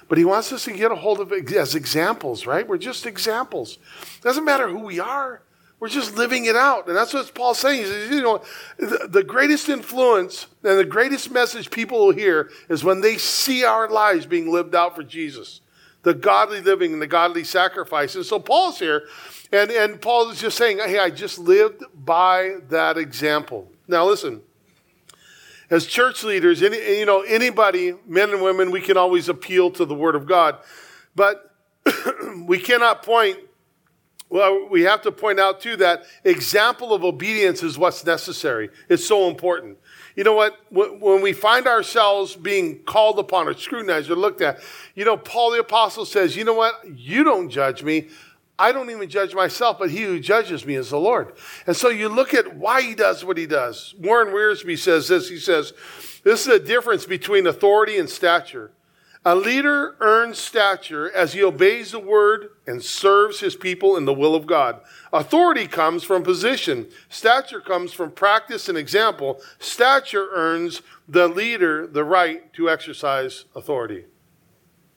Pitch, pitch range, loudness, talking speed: 220 Hz, 185-290 Hz, -19 LUFS, 180 wpm